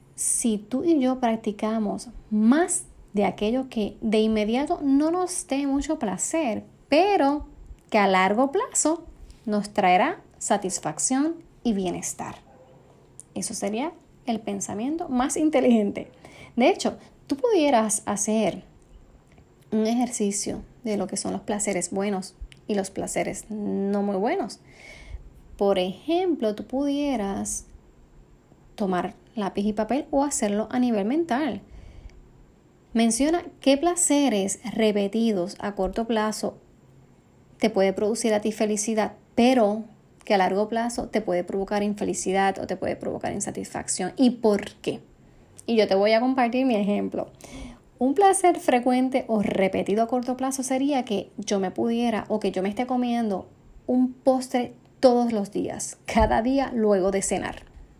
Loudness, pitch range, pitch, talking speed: -24 LUFS, 200-260 Hz, 220 Hz, 135 wpm